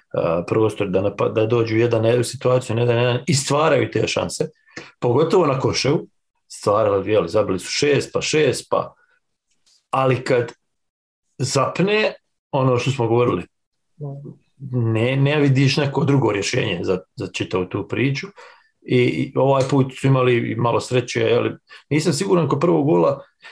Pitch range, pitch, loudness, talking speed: 120-150 Hz, 130 Hz, -19 LUFS, 145 wpm